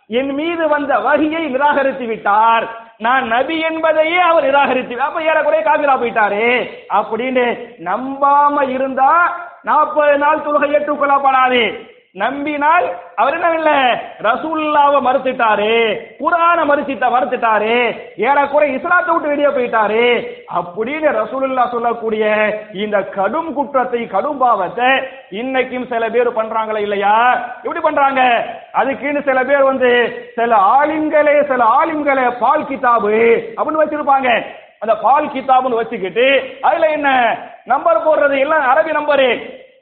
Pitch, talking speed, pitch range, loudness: 275 Hz, 100 wpm, 240-310 Hz, -14 LUFS